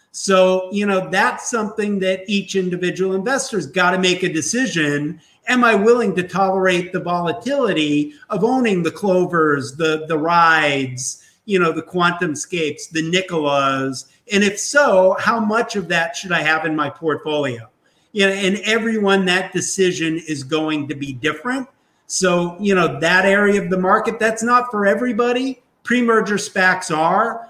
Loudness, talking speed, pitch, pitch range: -18 LUFS, 165 wpm, 185 Hz, 160-215 Hz